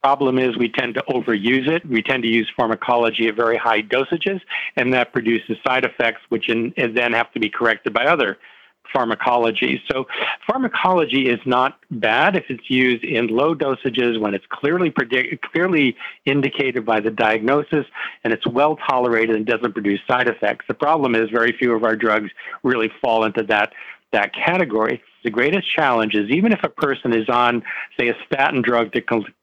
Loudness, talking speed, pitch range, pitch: -19 LUFS, 185 wpm, 115-130 Hz, 120 Hz